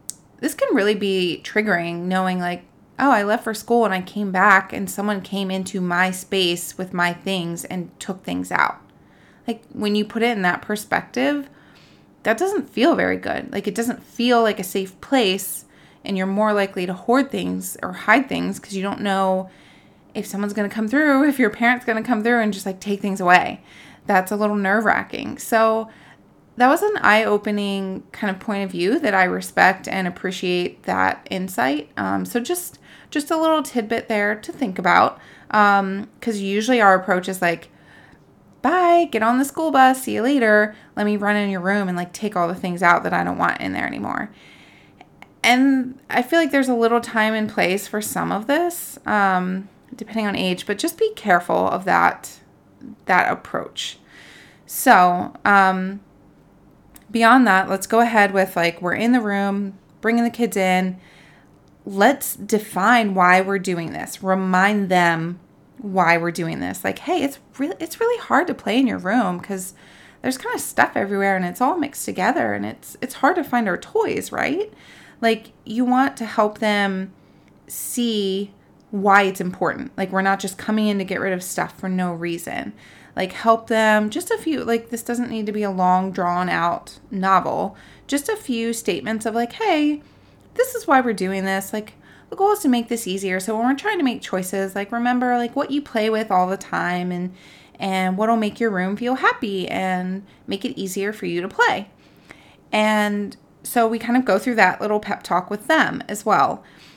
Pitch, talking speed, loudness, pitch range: 210 Hz, 195 wpm, -20 LUFS, 190-240 Hz